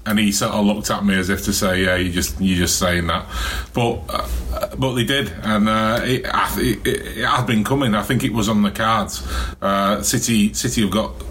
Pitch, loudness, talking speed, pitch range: 105 Hz, -19 LUFS, 235 wpm, 90-110 Hz